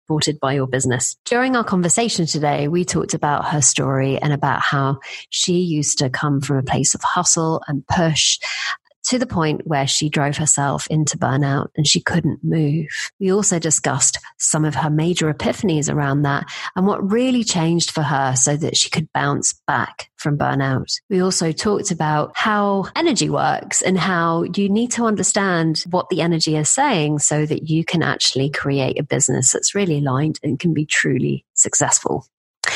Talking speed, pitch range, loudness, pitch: 180 wpm, 145-180 Hz, -18 LUFS, 155 Hz